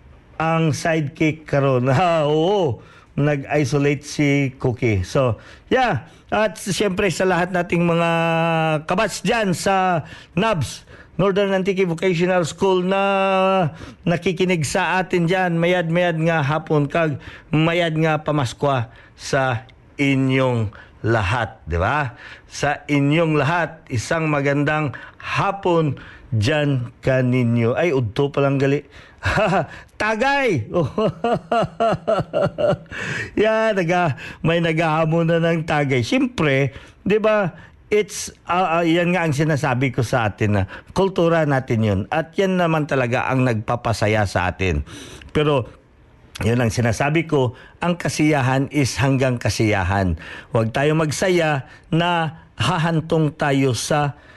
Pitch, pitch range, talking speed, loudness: 150 Hz, 130-175 Hz, 115 wpm, -20 LUFS